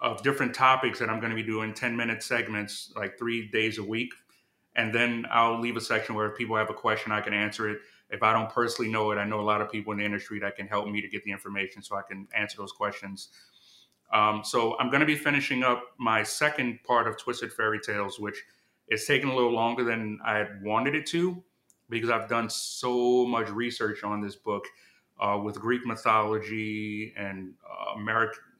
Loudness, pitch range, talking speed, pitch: -28 LUFS, 105-120 Hz, 215 wpm, 110 Hz